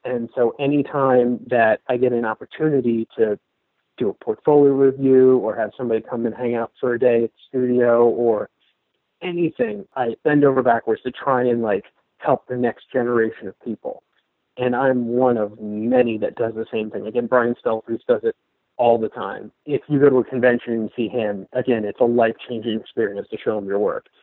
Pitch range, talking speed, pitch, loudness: 115-135 Hz, 200 wpm, 125 Hz, -20 LUFS